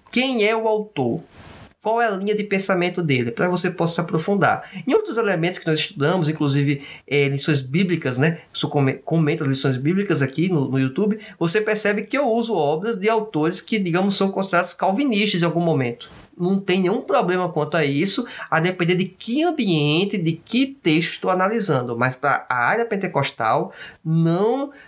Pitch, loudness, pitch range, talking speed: 180 Hz, -21 LUFS, 155-210 Hz, 180 wpm